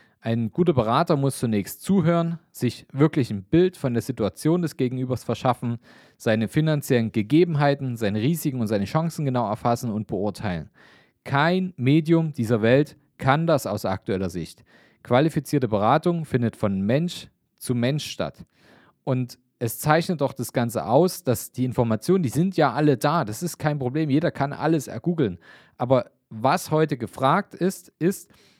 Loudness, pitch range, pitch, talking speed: -23 LUFS, 115-160 Hz, 135 Hz, 155 wpm